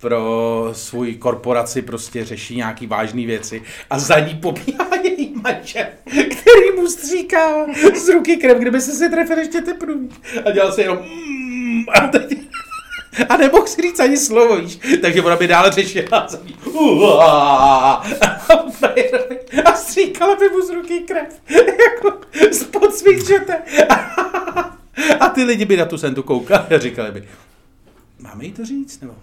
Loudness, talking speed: -14 LUFS, 155 wpm